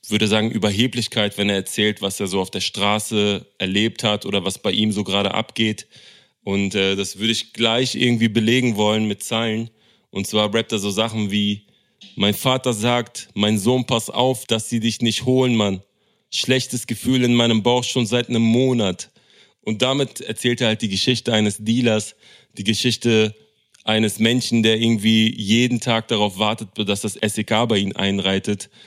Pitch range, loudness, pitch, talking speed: 105-120 Hz, -19 LUFS, 110 Hz, 180 wpm